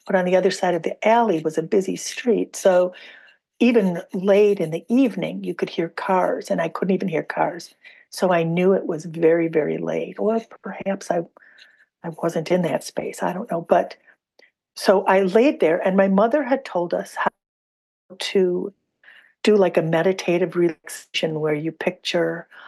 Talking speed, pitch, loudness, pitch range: 185 wpm, 185 Hz, -21 LUFS, 165-205 Hz